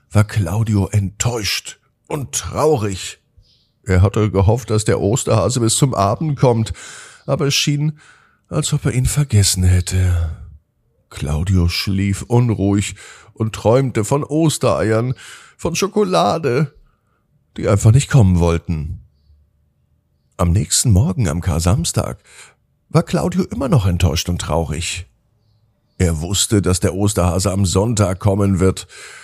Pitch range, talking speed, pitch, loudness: 95-130 Hz, 120 wpm, 105 Hz, -17 LUFS